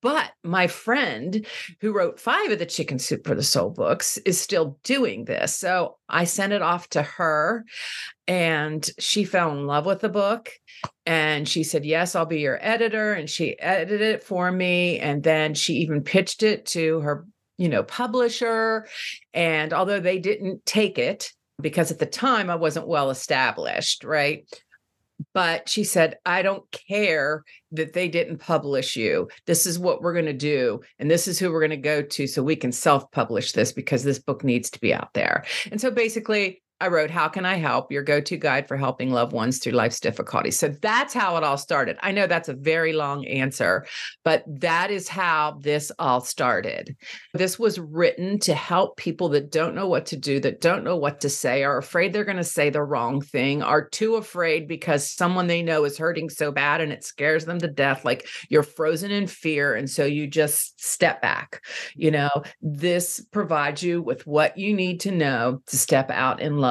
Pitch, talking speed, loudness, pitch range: 165 Hz, 200 wpm, -23 LUFS, 145-185 Hz